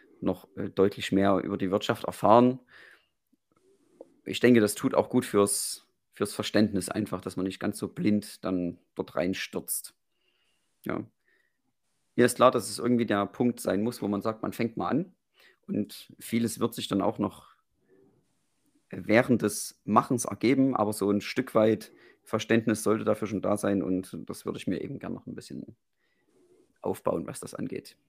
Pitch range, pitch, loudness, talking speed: 100-115 Hz, 105 Hz, -28 LUFS, 170 wpm